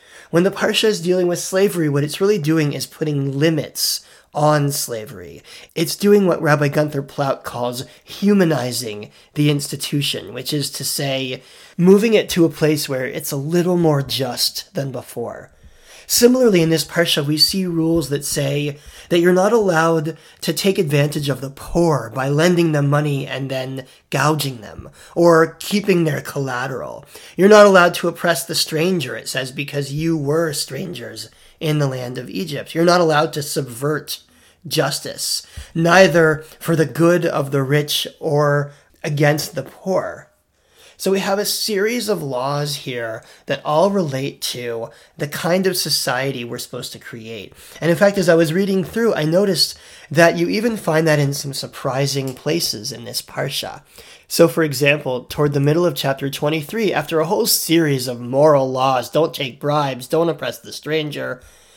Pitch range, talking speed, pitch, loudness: 140-175 Hz, 170 wpm, 155 Hz, -18 LUFS